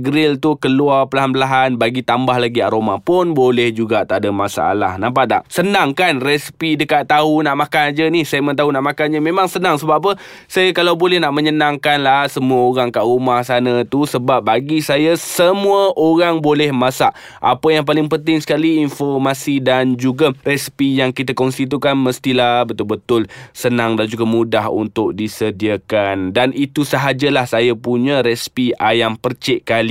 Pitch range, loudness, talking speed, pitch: 125-150 Hz, -15 LUFS, 170 wpm, 135 Hz